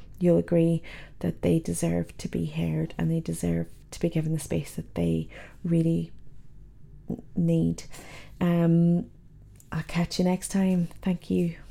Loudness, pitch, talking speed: -27 LUFS, 160 Hz, 145 wpm